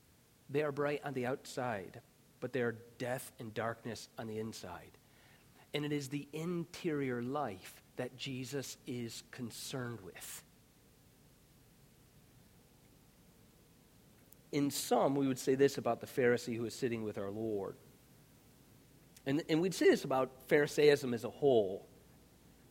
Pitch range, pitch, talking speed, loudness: 115-145 Hz, 130 Hz, 135 wpm, -36 LUFS